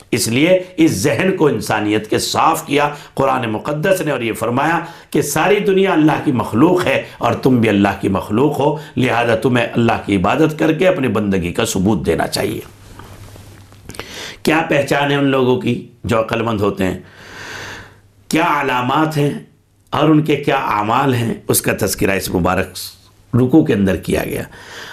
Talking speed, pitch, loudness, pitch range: 175 wpm, 115 Hz, -16 LUFS, 100-145 Hz